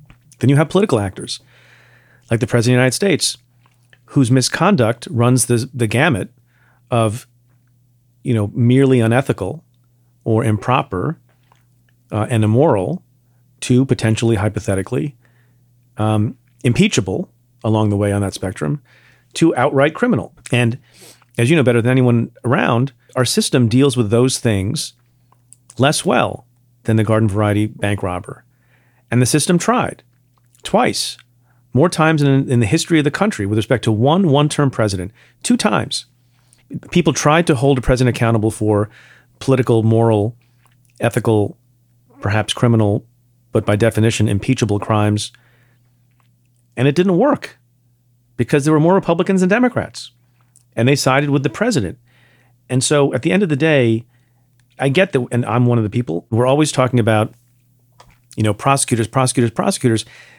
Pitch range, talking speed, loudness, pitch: 115-135 Hz, 145 wpm, -16 LUFS, 125 Hz